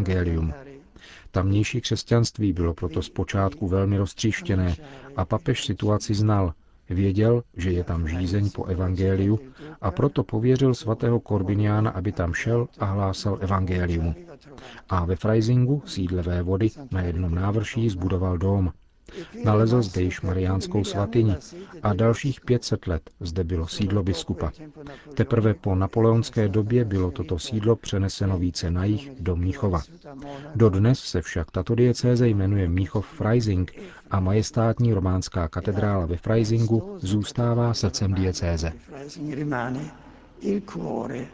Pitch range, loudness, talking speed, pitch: 95-115 Hz, -24 LUFS, 120 wpm, 100 Hz